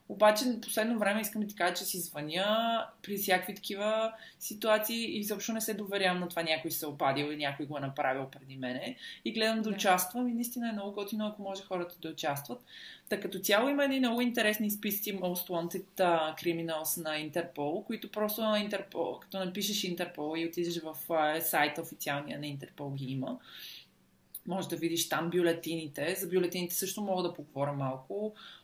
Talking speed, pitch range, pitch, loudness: 180 wpm, 155-210 Hz, 185 Hz, -33 LUFS